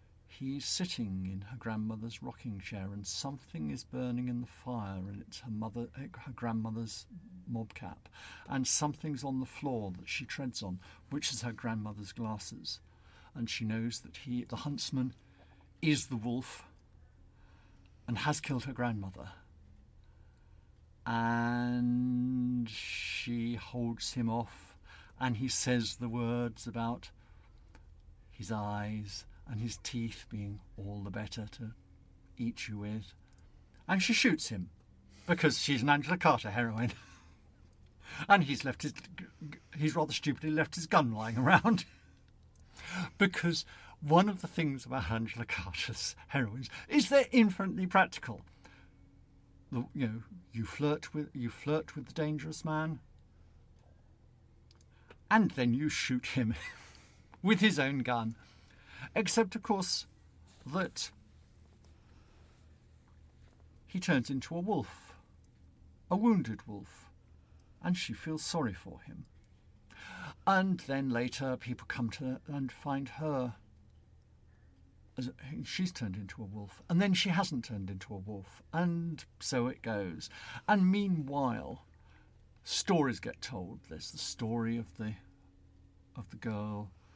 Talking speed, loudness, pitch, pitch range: 130 wpm, -34 LUFS, 115 Hz, 95-135 Hz